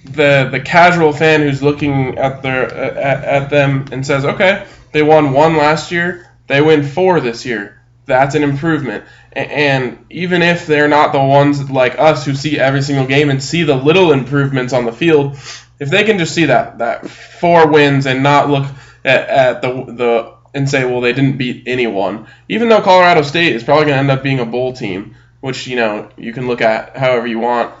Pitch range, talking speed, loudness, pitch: 125-155 Hz, 210 wpm, -13 LUFS, 140 Hz